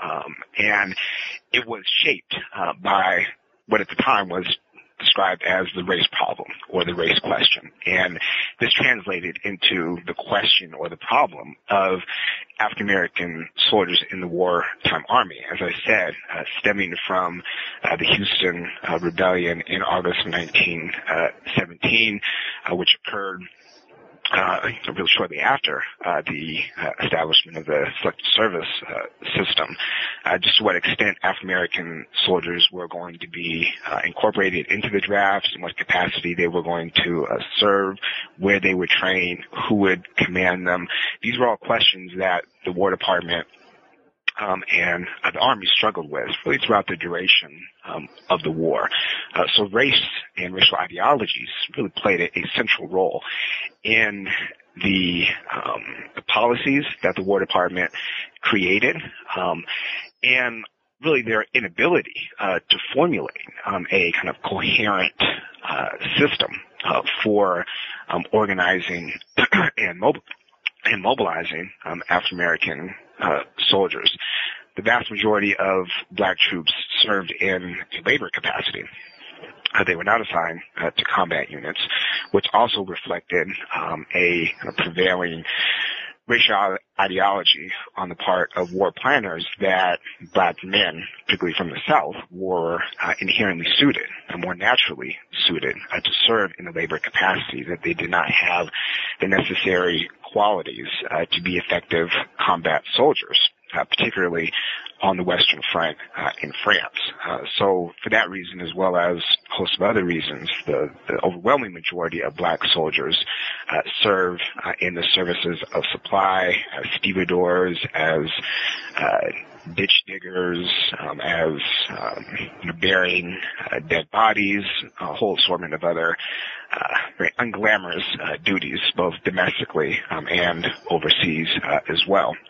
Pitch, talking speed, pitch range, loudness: 90 Hz, 145 wpm, 85-95 Hz, -21 LUFS